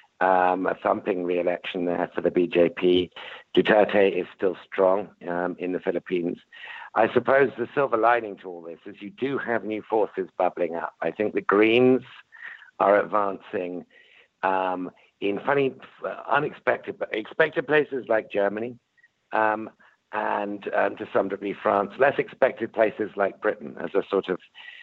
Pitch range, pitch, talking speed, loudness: 90-120 Hz, 105 Hz, 150 wpm, -25 LUFS